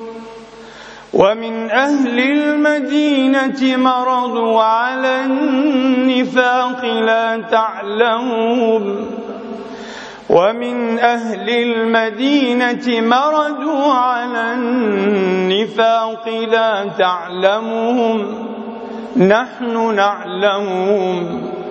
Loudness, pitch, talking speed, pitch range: -15 LUFS, 230 Hz, 50 wpm, 225-250 Hz